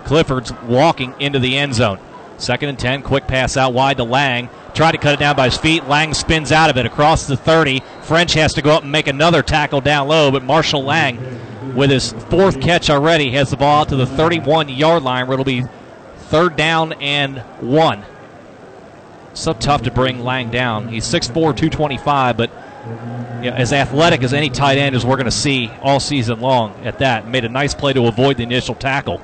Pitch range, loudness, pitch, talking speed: 125-155 Hz, -15 LUFS, 140 Hz, 210 wpm